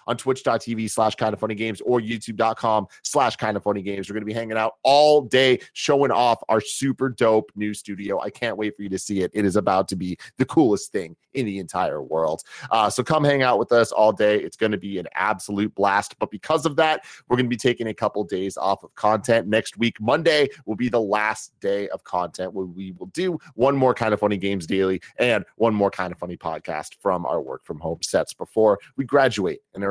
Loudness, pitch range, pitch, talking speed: -22 LUFS, 100-125 Hz, 110 Hz, 240 wpm